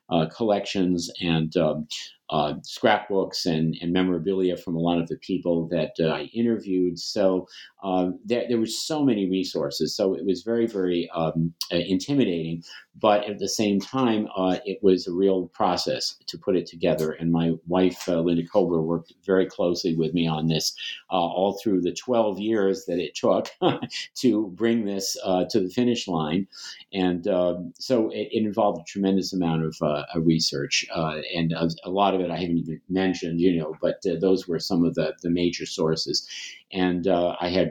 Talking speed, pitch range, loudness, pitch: 190 wpm, 85-100 Hz, -25 LUFS, 90 Hz